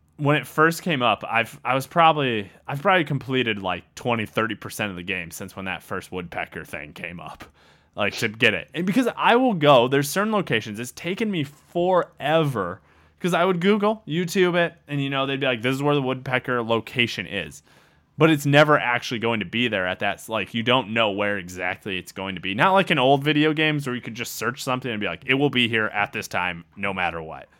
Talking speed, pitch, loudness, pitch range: 230 wpm, 130 Hz, -22 LUFS, 105-155 Hz